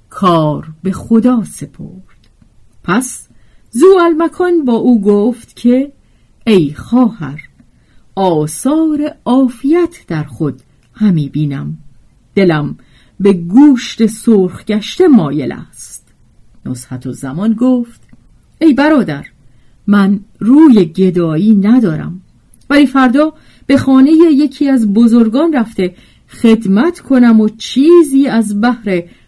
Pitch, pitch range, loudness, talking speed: 220 Hz, 165-265 Hz, -11 LUFS, 100 wpm